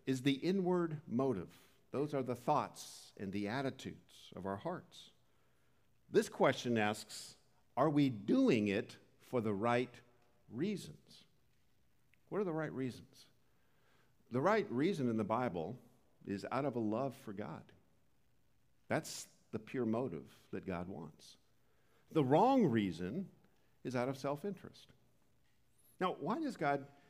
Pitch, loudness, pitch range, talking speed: 130 Hz, -38 LUFS, 115-155 Hz, 135 wpm